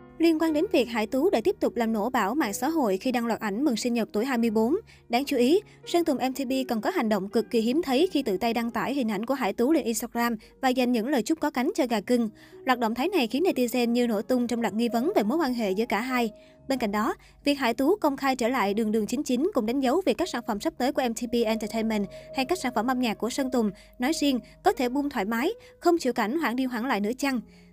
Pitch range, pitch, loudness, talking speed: 225-285 Hz, 245 Hz, -26 LUFS, 280 wpm